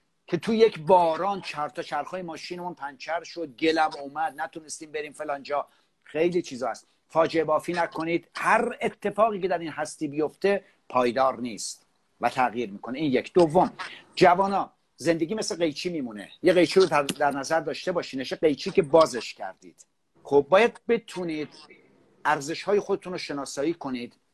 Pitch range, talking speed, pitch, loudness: 145-185 Hz, 150 wpm, 165 Hz, -26 LUFS